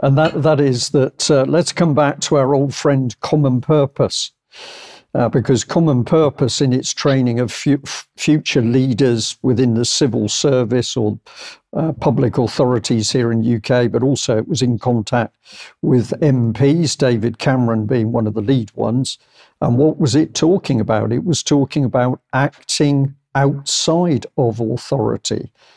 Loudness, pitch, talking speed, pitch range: -16 LUFS, 130 Hz, 155 wpm, 120-145 Hz